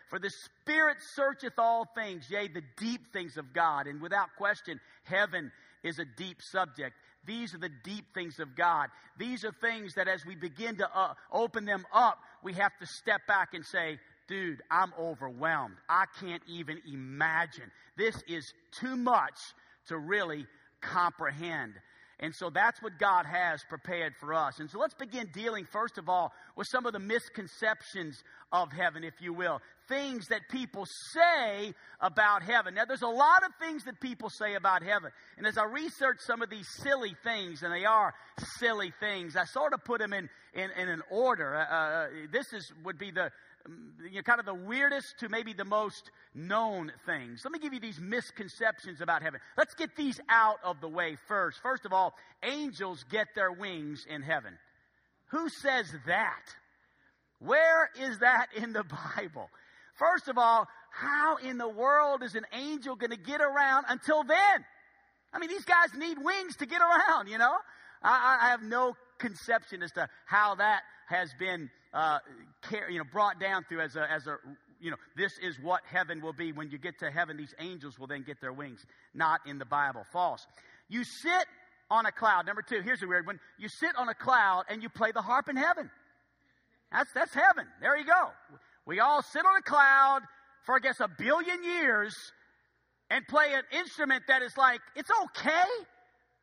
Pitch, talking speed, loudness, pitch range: 215 Hz, 190 wpm, -30 LUFS, 175-265 Hz